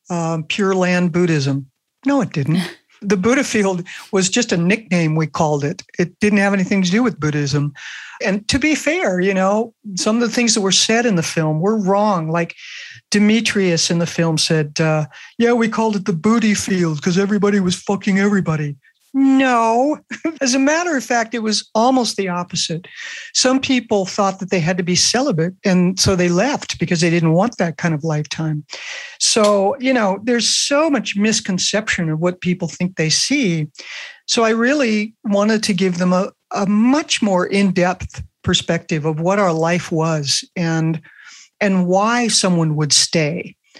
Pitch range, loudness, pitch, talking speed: 170-225 Hz, -17 LUFS, 195 Hz, 180 wpm